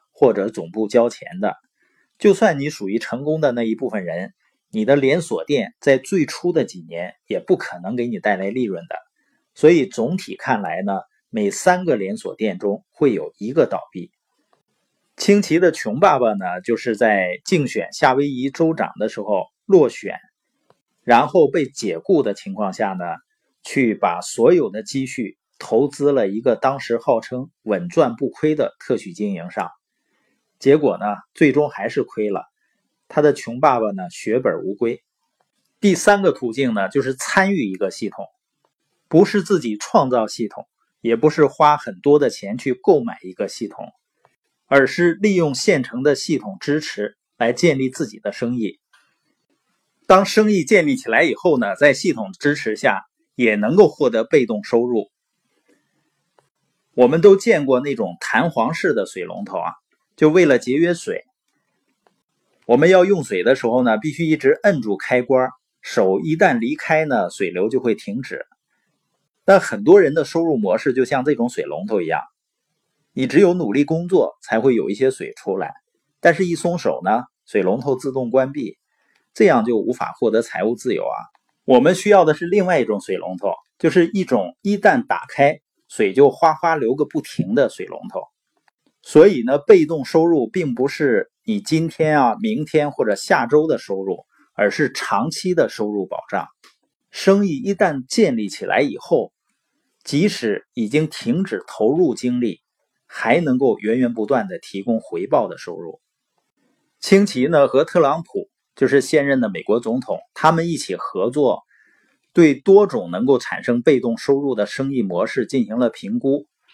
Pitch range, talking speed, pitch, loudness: 130-200 Hz, 240 characters per minute, 155 Hz, -18 LUFS